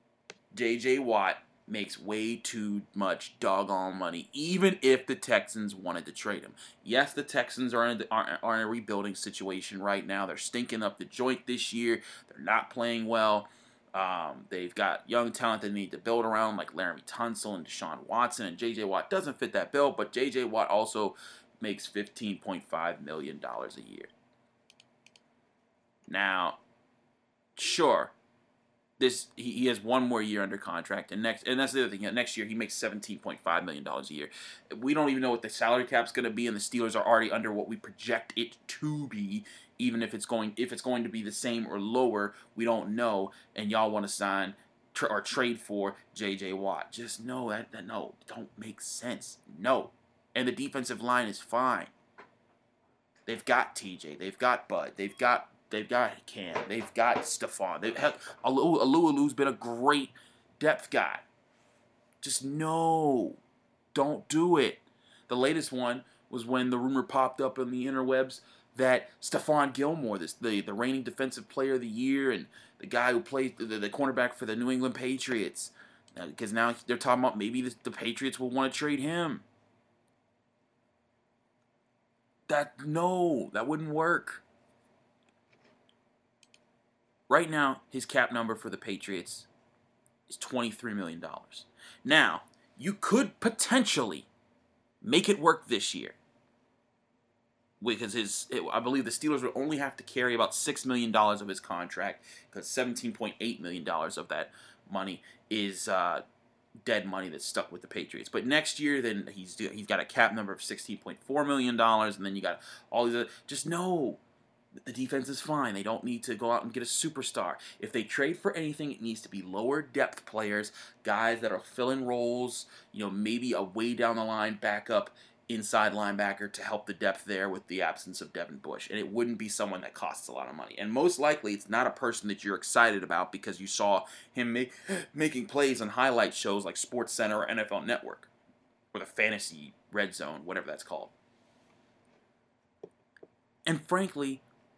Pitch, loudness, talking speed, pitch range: 120 Hz, -31 LUFS, 175 wpm, 110-130 Hz